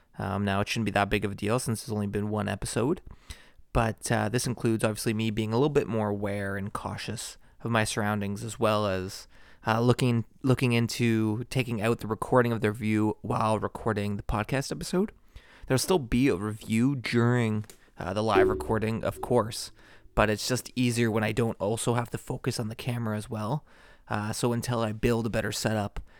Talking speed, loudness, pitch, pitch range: 200 wpm, -28 LUFS, 110 Hz, 105-120 Hz